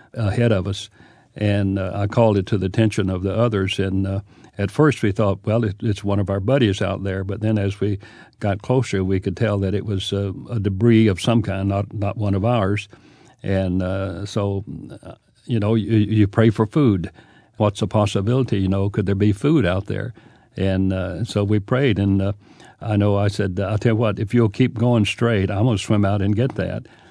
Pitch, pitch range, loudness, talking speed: 105 Hz, 100-115 Hz, -20 LUFS, 220 wpm